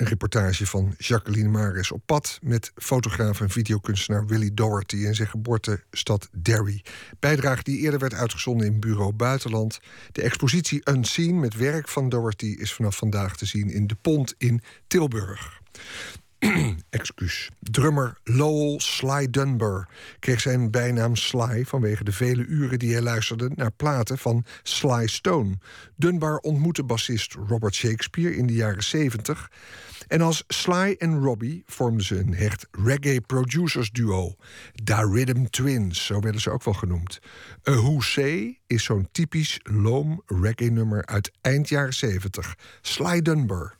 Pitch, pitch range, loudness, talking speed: 115 Hz, 105-140 Hz, -24 LUFS, 145 wpm